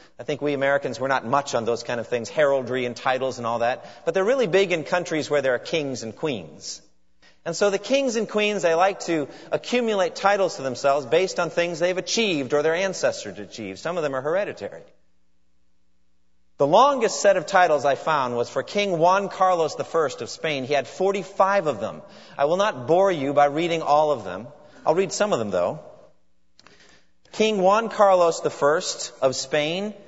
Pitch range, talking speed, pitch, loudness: 125-190 Hz, 195 wpm, 150 Hz, -22 LUFS